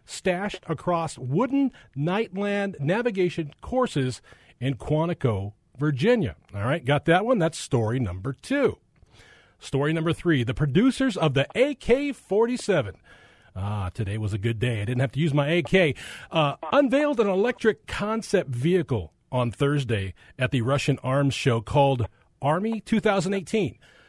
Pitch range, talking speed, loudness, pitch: 130-200 Hz, 140 wpm, -25 LUFS, 155 Hz